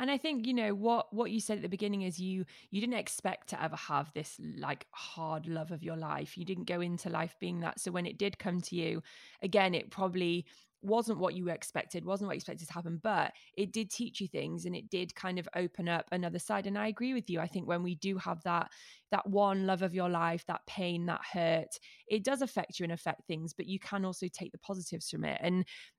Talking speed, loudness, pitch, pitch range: 250 wpm, -36 LUFS, 185 Hz, 170-205 Hz